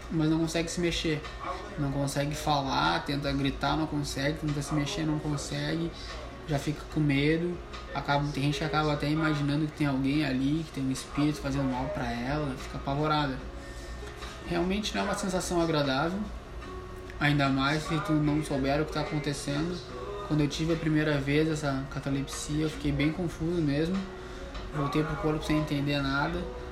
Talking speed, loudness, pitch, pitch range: 170 wpm, -30 LUFS, 145 Hz, 140-155 Hz